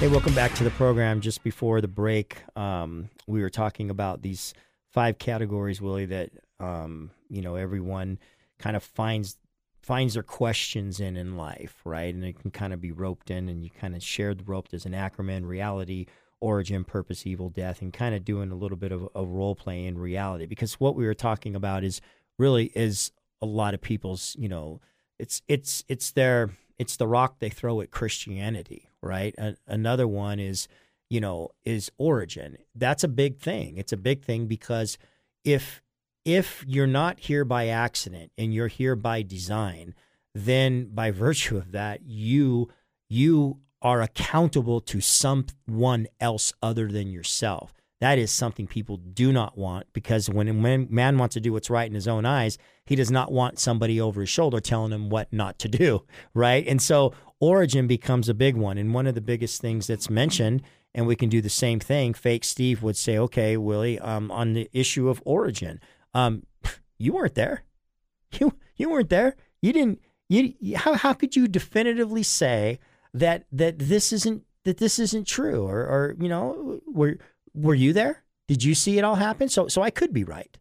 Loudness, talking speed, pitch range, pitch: -26 LUFS, 190 wpm, 100-135 Hz, 115 Hz